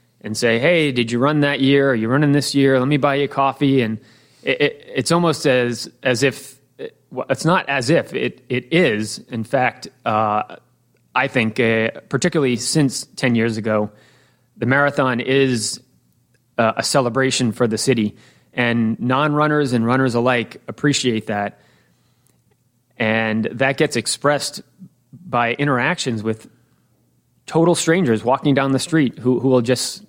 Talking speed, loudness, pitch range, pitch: 160 wpm, -18 LUFS, 115-140 Hz, 130 Hz